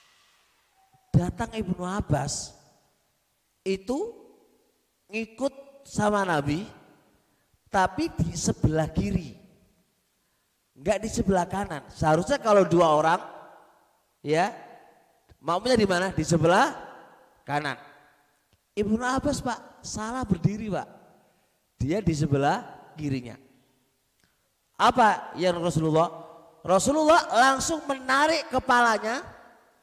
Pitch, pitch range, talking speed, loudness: 190 Hz, 155-245 Hz, 85 wpm, -25 LUFS